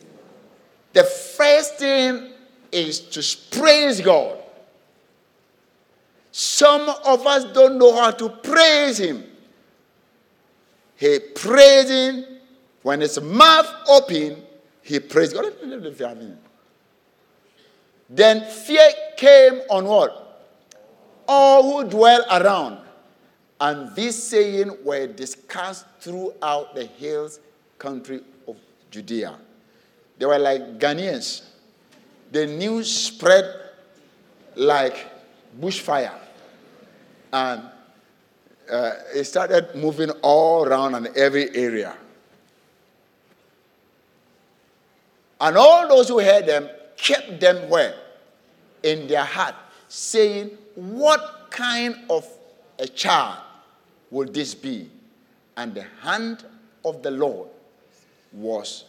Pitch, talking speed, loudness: 220 Hz, 95 wpm, -17 LUFS